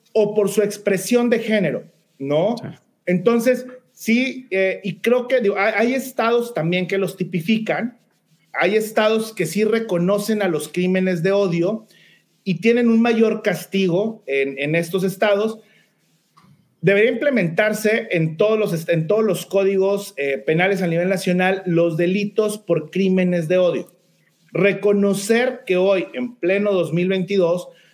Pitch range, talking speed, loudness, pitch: 175-220 Hz, 140 wpm, -19 LUFS, 195 Hz